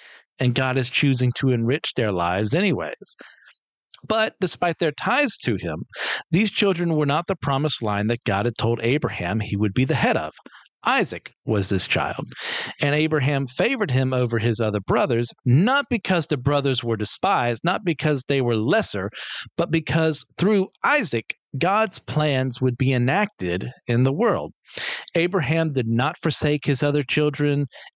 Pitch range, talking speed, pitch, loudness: 120-160 Hz, 160 wpm, 140 Hz, -22 LUFS